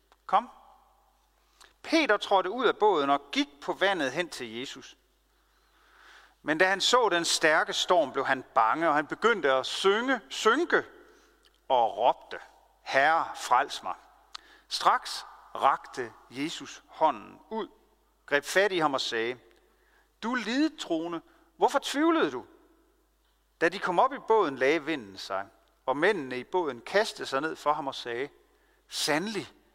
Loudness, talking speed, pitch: -27 LUFS, 145 wpm, 250 Hz